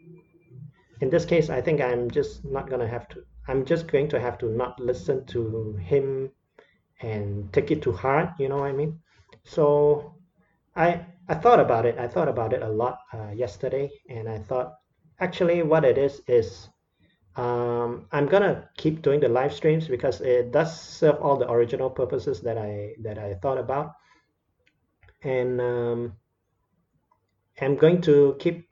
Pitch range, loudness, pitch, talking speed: 120-160 Hz, -25 LUFS, 135 Hz, 170 wpm